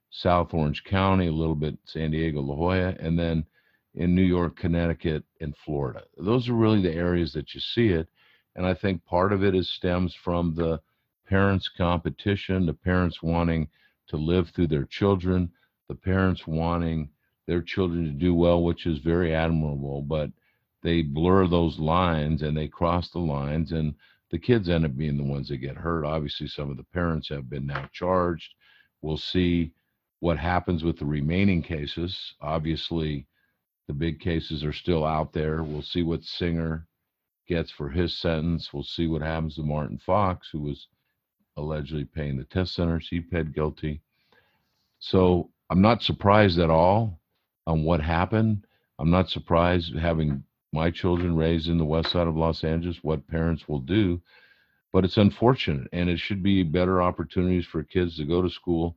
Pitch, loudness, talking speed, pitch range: 85 Hz, -26 LUFS, 175 wpm, 80-90 Hz